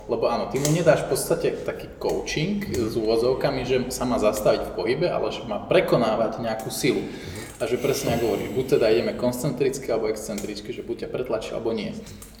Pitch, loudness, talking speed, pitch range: 130 Hz, -24 LUFS, 195 wpm, 115-175 Hz